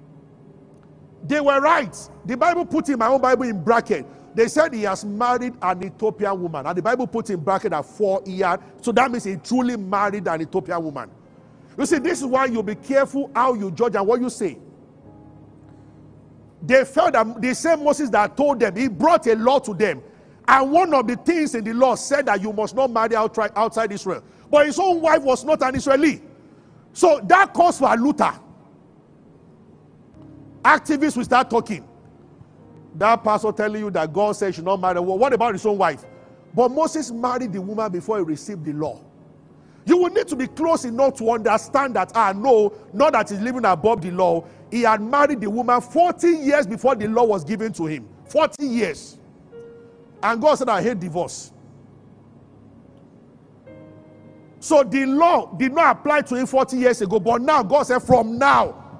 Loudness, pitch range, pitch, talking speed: -20 LUFS, 205-275 Hz, 235 Hz, 190 wpm